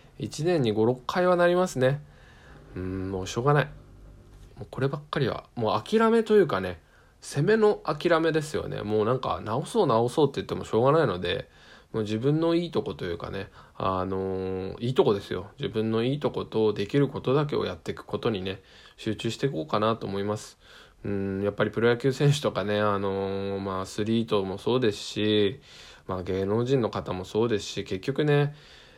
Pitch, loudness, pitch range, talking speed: 110 Hz, -27 LUFS, 100-140 Hz, 375 characters per minute